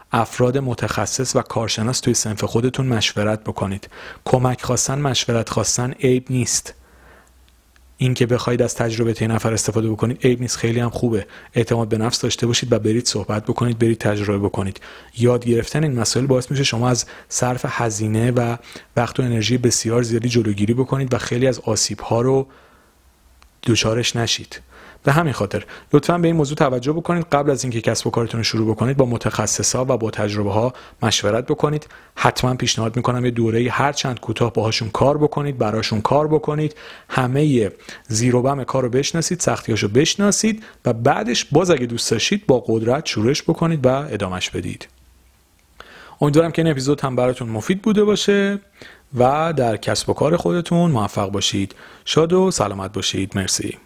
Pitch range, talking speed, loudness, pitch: 110-135 Hz, 165 wpm, -19 LUFS, 120 Hz